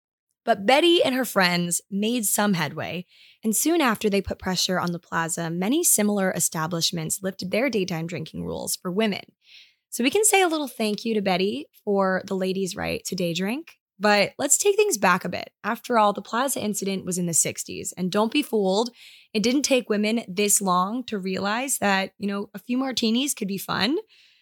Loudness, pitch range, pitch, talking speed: -23 LUFS, 185-240 Hz, 205 Hz, 200 wpm